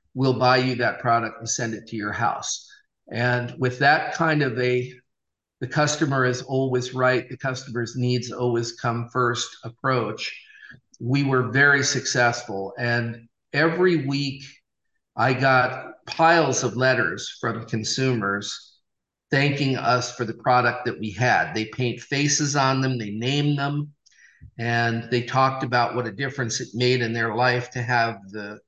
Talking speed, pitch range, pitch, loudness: 155 wpm, 120-135 Hz, 125 Hz, -23 LUFS